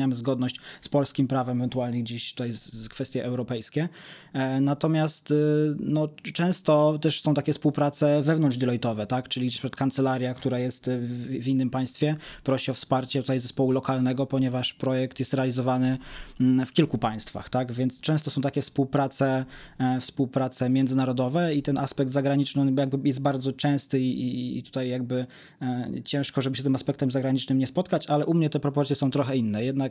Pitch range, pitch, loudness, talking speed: 130-145 Hz, 135 Hz, -26 LUFS, 155 wpm